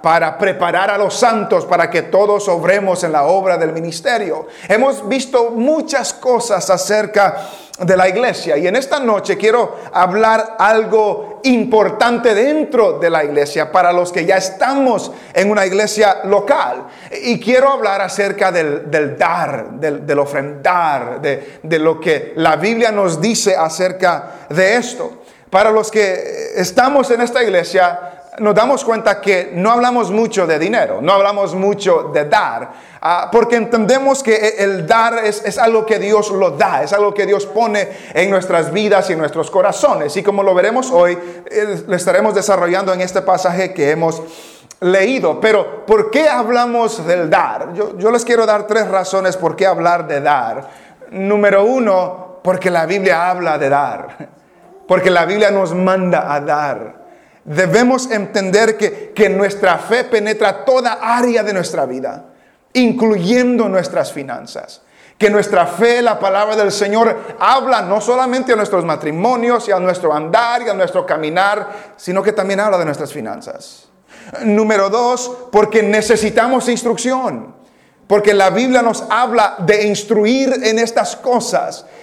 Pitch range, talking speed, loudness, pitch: 185-230 Hz, 155 wpm, -14 LUFS, 205 Hz